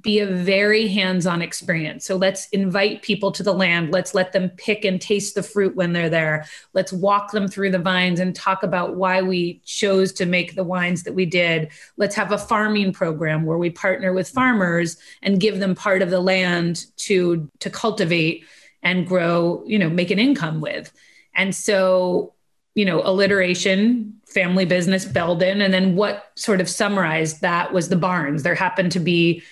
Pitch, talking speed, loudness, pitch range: 185 Hz, 185 wpm, -20 LUFS, 175-200 Hz